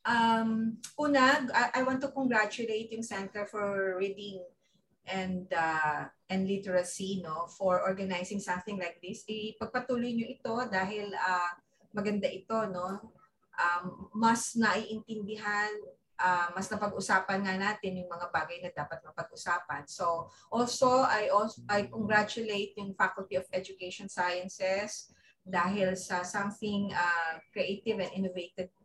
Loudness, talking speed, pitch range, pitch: -32 LUFS, 125 wpm, 180-215 Hz, 195 Hz